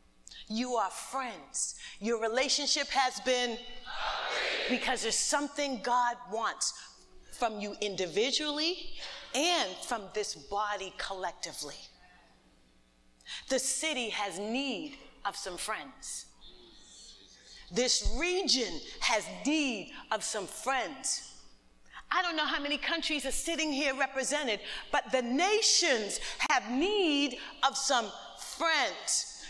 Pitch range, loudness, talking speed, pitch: 210-285 Hz, -31 LUFS, 105 wpm, 255 Hz